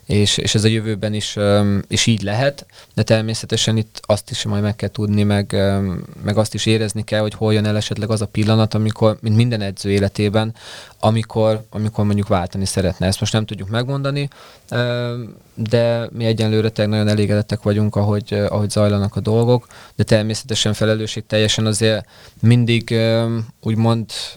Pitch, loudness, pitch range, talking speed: 110 Hz, -18 LUFS, 105-115 Hz, 160 wpm